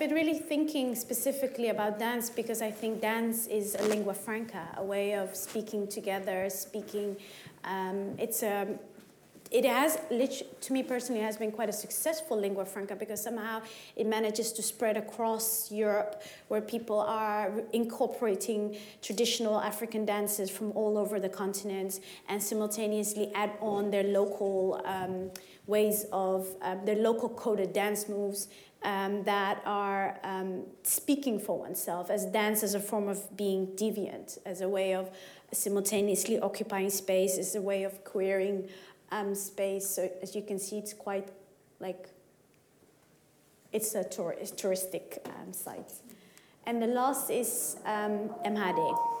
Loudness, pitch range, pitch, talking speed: -32 LUFS, 195-220 Hz, 210 Hz, 150 wpm